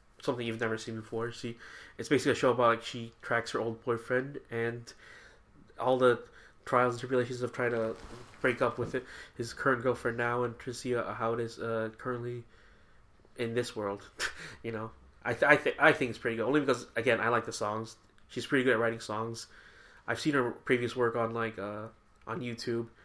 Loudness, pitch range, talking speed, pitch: -32 LUFS, 115-120 Hz, 205 wpm, 115 Hz